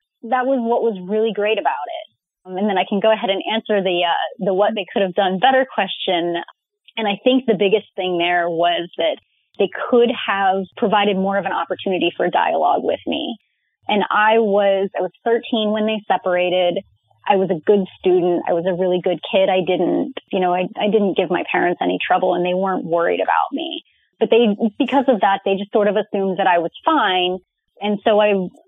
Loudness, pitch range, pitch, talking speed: -18 LUFS, 185-220 Hz, 195 Hz, 215 wpm